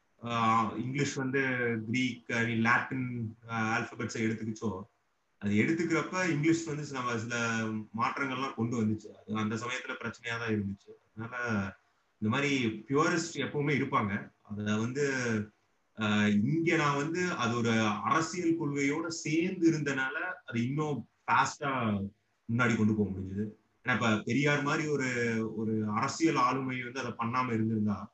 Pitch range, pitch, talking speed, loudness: 110-140 Hz, 120 Hz, 120 wpm, -31 LUFS